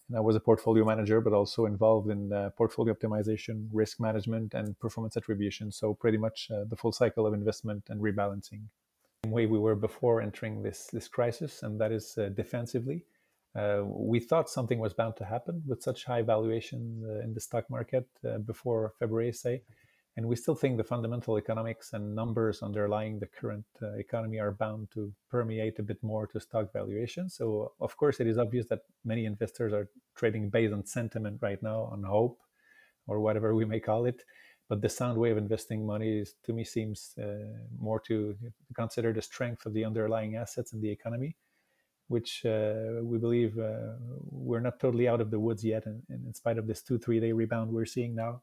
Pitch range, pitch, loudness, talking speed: 110-120 Hz, 110 Hz, -32 LUFS, 200 wpm